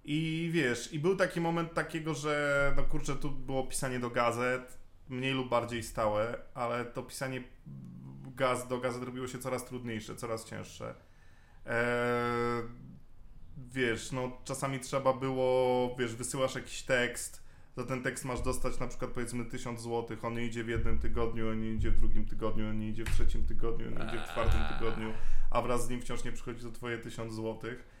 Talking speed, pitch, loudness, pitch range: 175 wpm, 120 Hz, -35 LUFS, 115-130 Hz